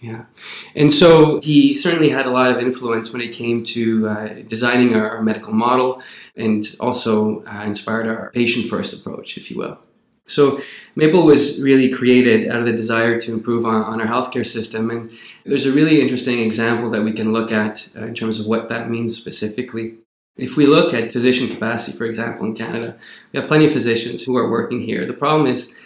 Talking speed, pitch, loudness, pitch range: 205 wpm, 115 Hz, -17 LUFS, 115-125 Hz